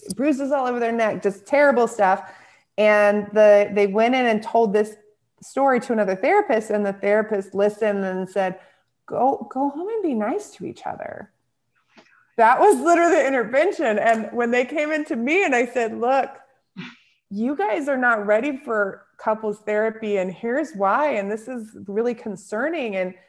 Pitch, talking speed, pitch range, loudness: 225 Hz, 175 wpm, 205-270 Hz, -21 LUFS